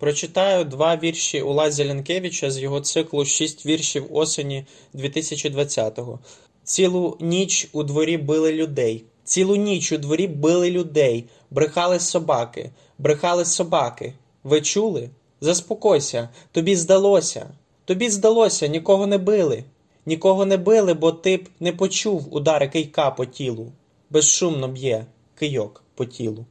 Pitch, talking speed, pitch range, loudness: 155 Hz, 125 wpm, 140-185 Hz, -20 LUFS